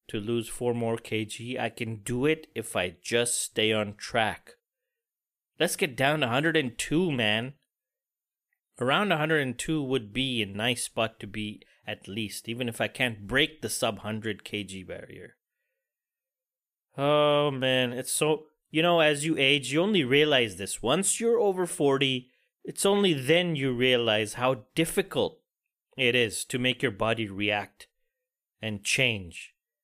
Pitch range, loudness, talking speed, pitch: 115-160 Hz, -27 LUFS, 150 wpm, 130 Hz